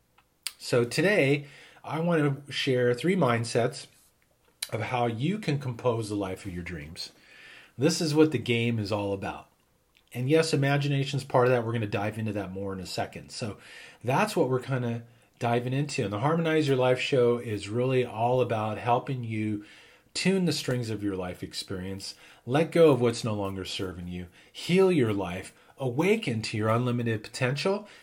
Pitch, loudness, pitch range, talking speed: 120 Hz, -28 LUFS, 105-140 Hz, 185 wpm